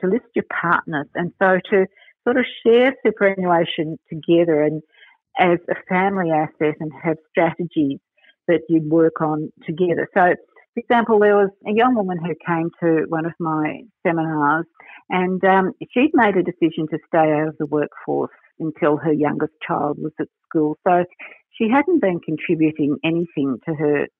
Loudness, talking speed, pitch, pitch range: -20 LUFS, 165 wpm, 170 Hz, 155-195 Hz